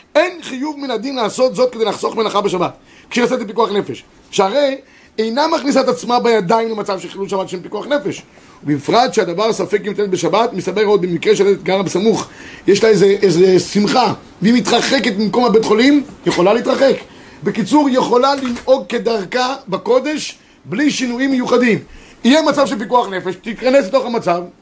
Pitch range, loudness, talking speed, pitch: 200-255 Hz, -15 LUFS, 165 wpm, 230 Hz